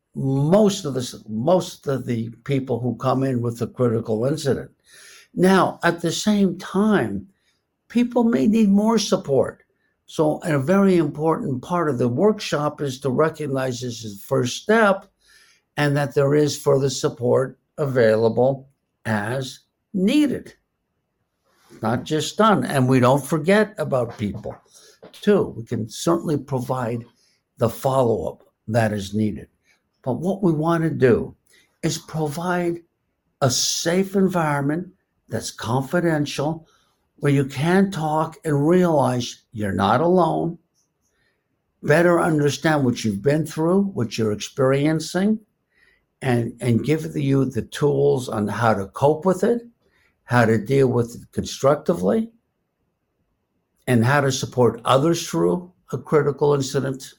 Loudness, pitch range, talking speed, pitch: -21 LUFS, 125-175 Hz, 135 wpm, 145 Hz